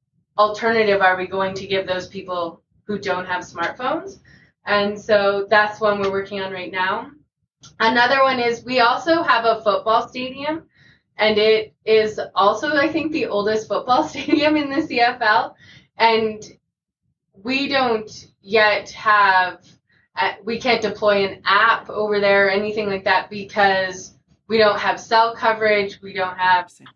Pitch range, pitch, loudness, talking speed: 195-230 Hz, 210 Hz, -19 LUFS, 150 wpm